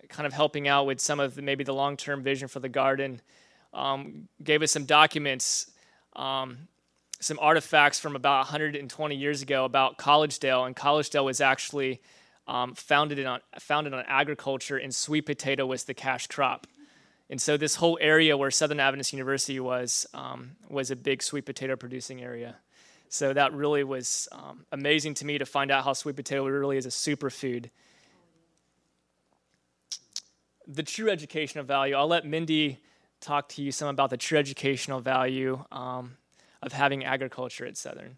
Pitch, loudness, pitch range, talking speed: 140 Hz, -27 LUFS, 130-145 Hz, 165 wpm